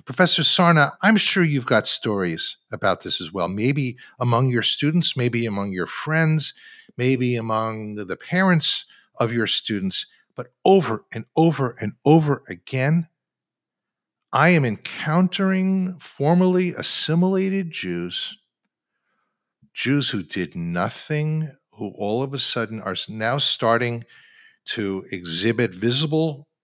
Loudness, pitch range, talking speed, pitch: -21 LUFS, 110-165 Hz, 120 wpm, 130 Hz